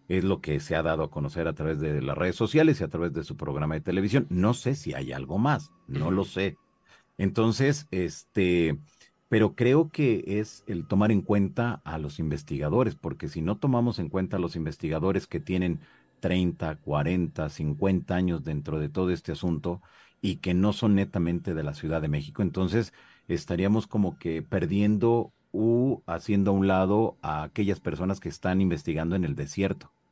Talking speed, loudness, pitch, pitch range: 185 wpm, -28 LUFS, 95 Hz, 80-105 Hz